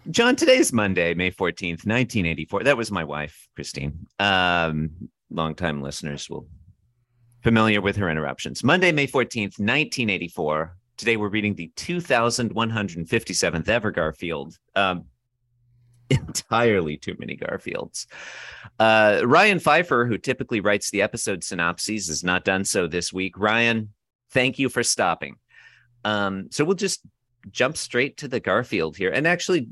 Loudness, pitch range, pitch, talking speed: -22 LUFS, 90-120 Hz, 105 Hz, 135 wpm